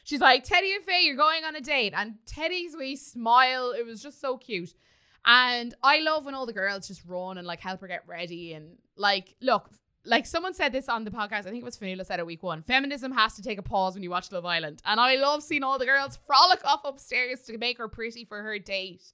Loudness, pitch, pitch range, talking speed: -26 LUFS, 235 Hz, 190-275 Hz, 255 wpm